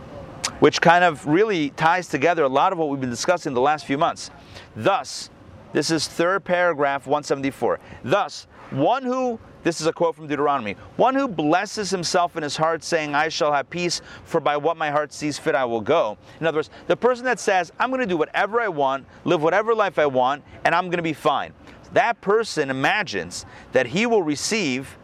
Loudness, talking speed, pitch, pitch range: -22 LUFS, 205 wpm, 165 Hz, 150-185 Hz